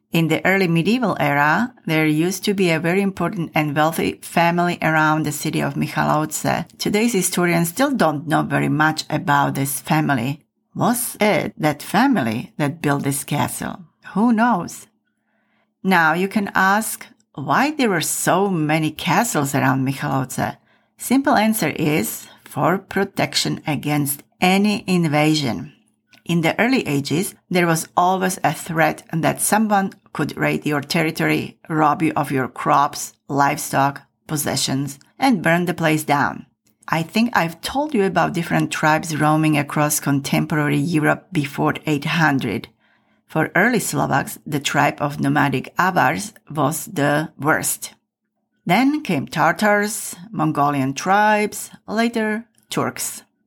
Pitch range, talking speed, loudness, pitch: 150-200 Hz, 135 wpm, -19 LUFS, 160 Hz